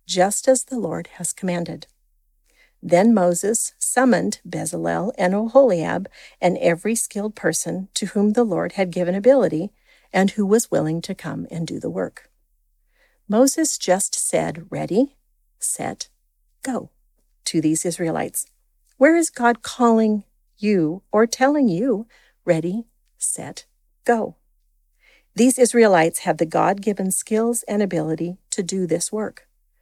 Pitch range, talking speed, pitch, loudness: 175-235 Hz, 130 wpm, 205 Hz, -20 LUFS